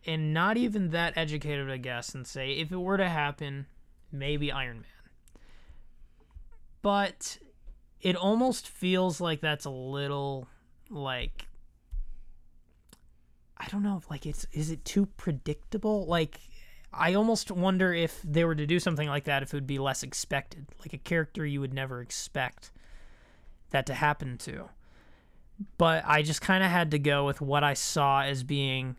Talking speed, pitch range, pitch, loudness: 160 wpm, 135-175 Hz, 150 Hz, -30 LUFS